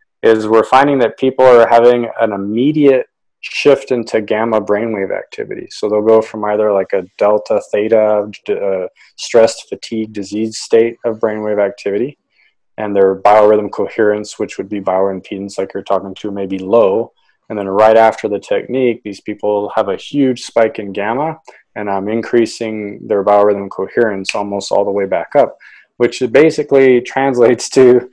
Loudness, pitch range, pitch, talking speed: -14 LUFS, 105-125 Hz, 110 Hz, 160 wpm